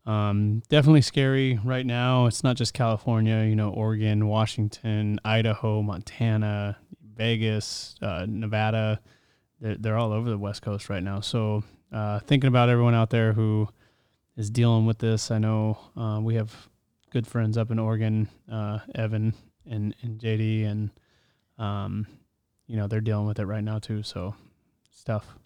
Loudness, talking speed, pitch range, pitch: -26 LUFS, 160 wpm, 105-115 Hz, 110 Hz